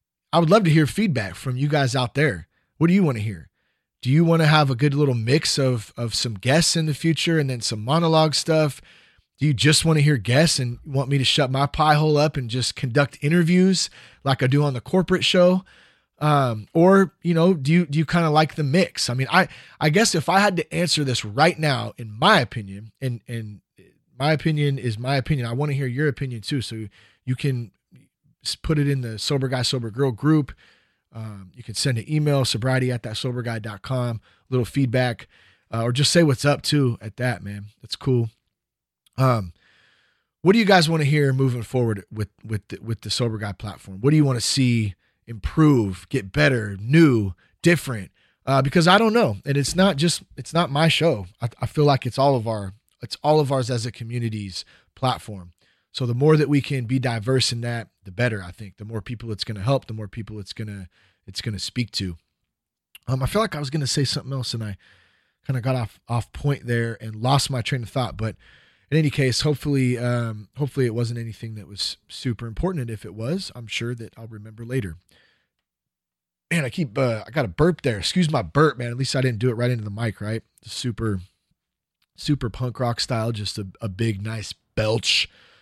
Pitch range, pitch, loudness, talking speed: 110-150 Hz, 130 Hz, -22 LUFS, 220 wpm